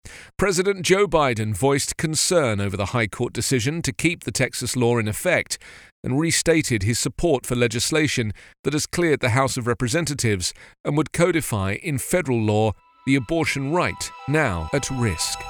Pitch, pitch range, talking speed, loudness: 130 Hz, 115-160 Hz, 165 wpm, -22 LUFS